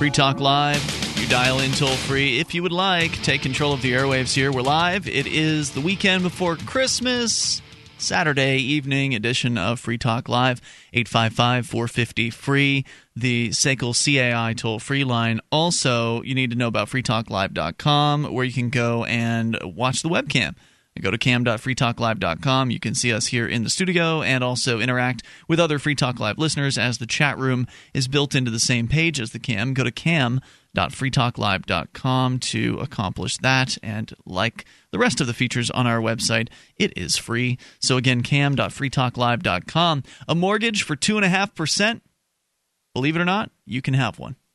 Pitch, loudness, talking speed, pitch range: 130 Hz, -21 LUFS, 170 wpm, 120-150 Hz